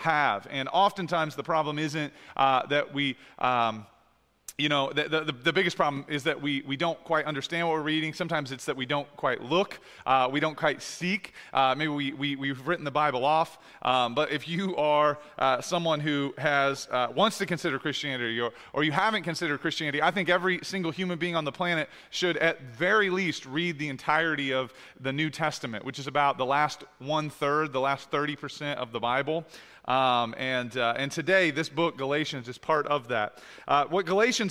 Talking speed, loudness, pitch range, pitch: 205 wpm, -28 LUFS, 135-165 Hz, 150 Hz